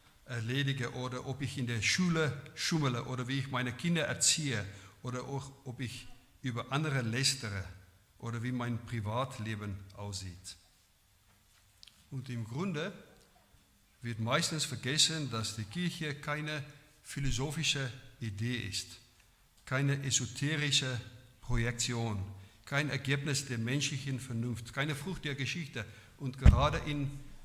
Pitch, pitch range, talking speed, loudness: 125 Hz, 115-140 Hz, 120 wpm, -34 LUFS